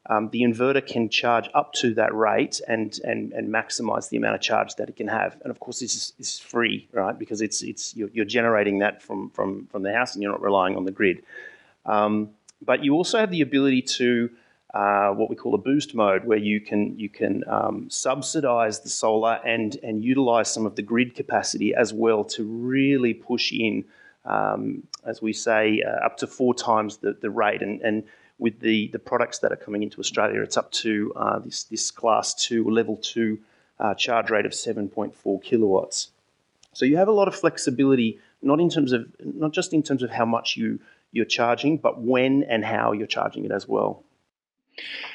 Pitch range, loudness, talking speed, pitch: 110-130 Hz, -24 LUFS, 205 wpm, 115 Hz